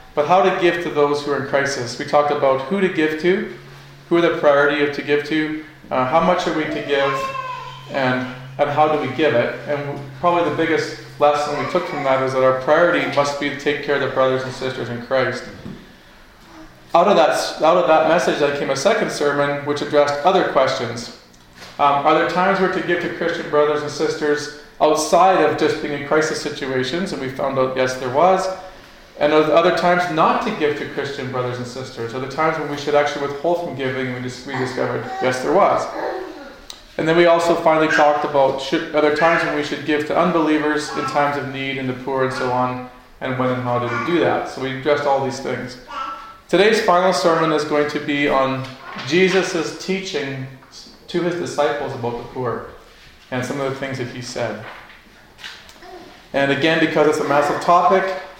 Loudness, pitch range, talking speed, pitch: -19 LUFS, 135-165 Hz, 210 wpm, 145 Hz